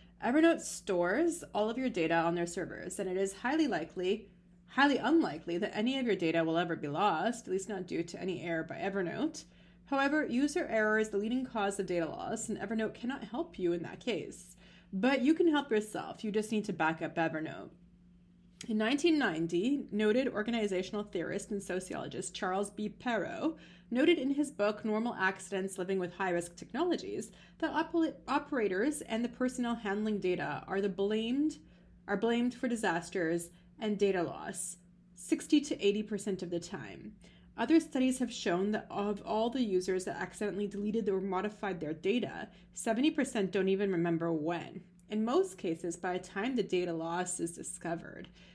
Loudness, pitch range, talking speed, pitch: -33 LUFS, 180-240 Hz, 175 wpm, 200 Hz